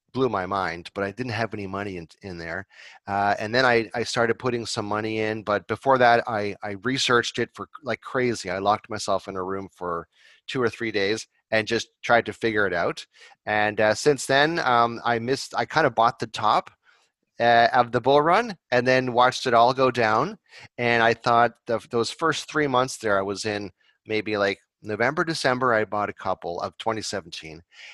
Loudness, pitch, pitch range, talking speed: -23 LUFS, 115 Hz, 100-125 Hz, 210 wpm